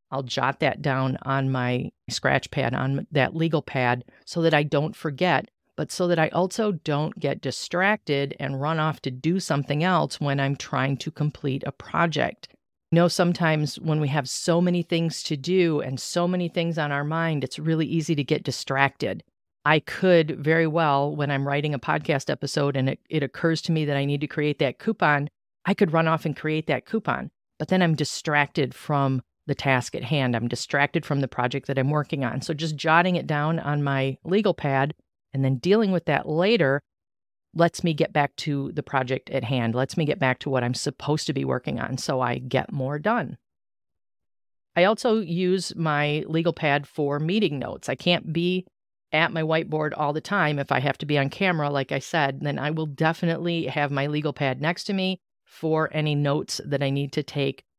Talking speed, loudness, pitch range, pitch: 210 wpm, -24 LUFS, 140-165 Hz, 150 Hz